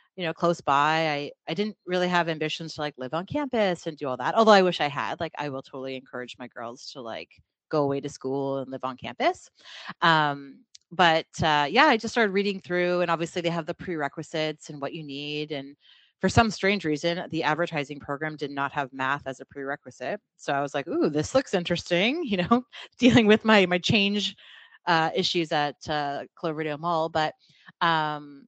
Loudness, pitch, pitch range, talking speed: -25 LUFS, 160 Hz, 145-180 Hz, 205 wpm